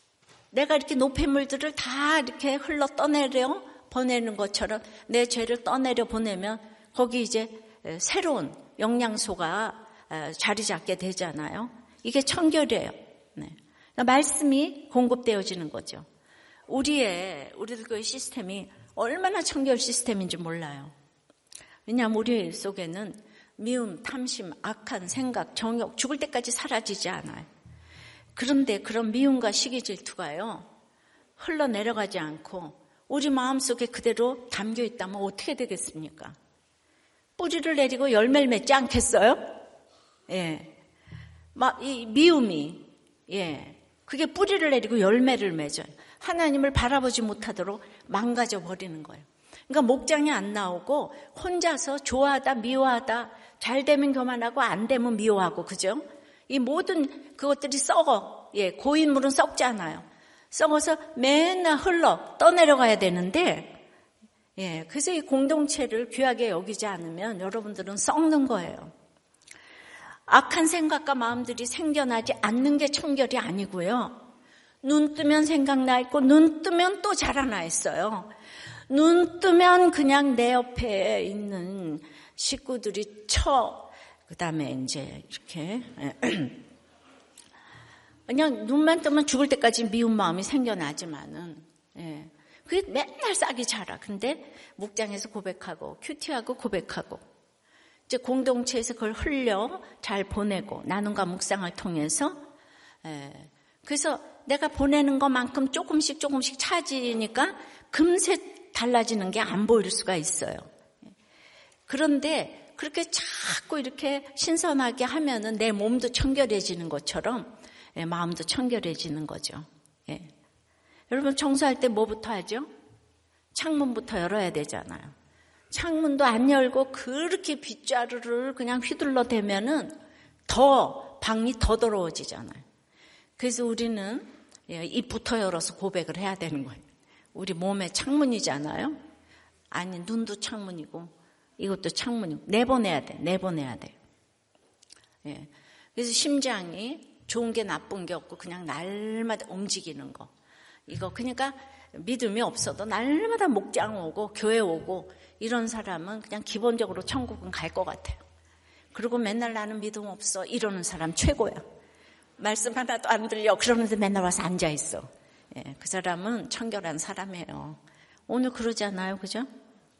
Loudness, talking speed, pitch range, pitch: -27 LUFS, 280 characters per minute, 195-280 Hz, 235 Hz